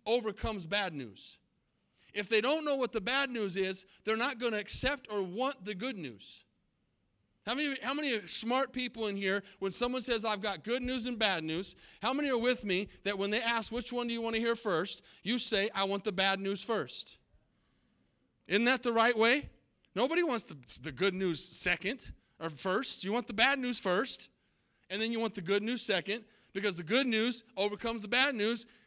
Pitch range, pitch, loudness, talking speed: 195-245 Hz, 220 Hz, -33 LUFS, 205 wpm